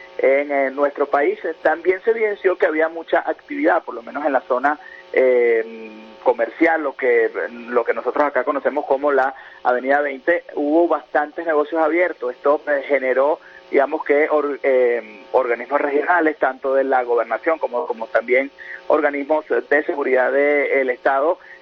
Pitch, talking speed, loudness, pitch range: 145 Hz, 155 wpm, -19 LUFS, 130-165 Hz